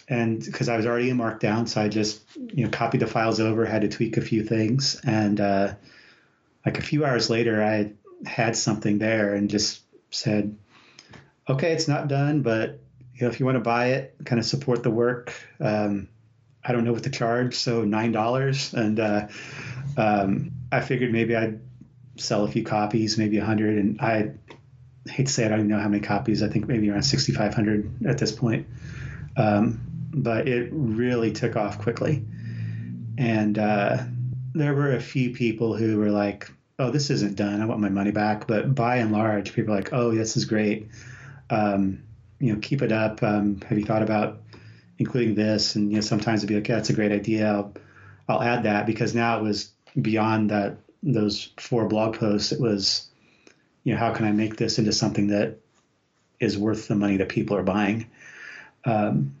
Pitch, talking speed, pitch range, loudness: 110 Hz, 200 wpm, 105-125 Hz, -24 LUFS